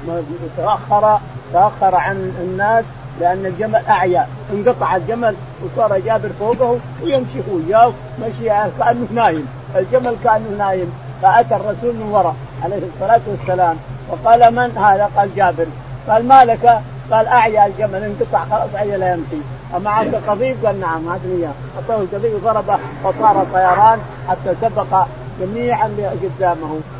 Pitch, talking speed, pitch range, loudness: 195 Hz, 130 wpm, 165-220 Hz, -16 LUFS